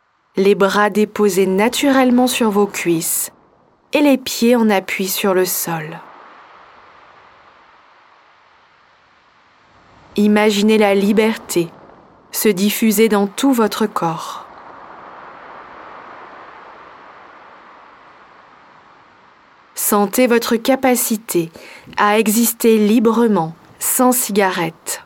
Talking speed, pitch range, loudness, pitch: 75 wpm, 185-230 Hz, -15 LUFS, 210 Hz